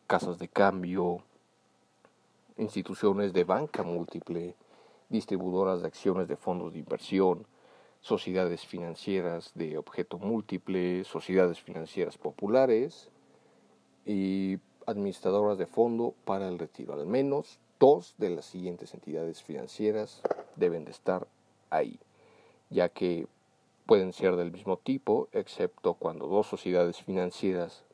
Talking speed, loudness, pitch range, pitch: 115 wpm, -31 LUFS, 90-100 Hz, 95 Hz